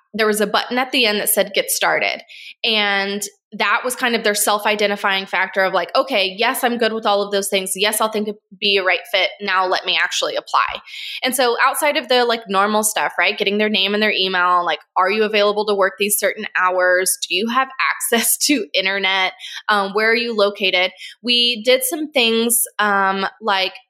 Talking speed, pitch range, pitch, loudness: 215 wpm, 195-235 Hz, 210 Hz, -17 LUFS